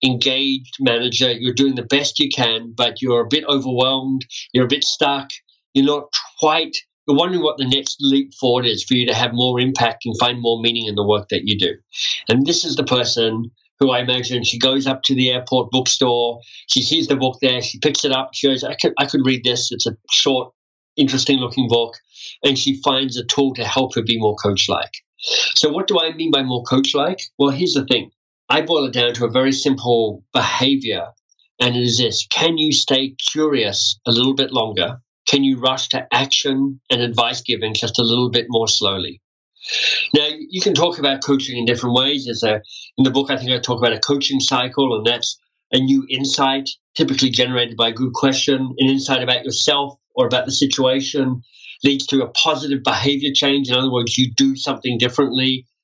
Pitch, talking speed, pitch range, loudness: 130 Hz, 210 wpm, 120-140 Hz, -17 LUFS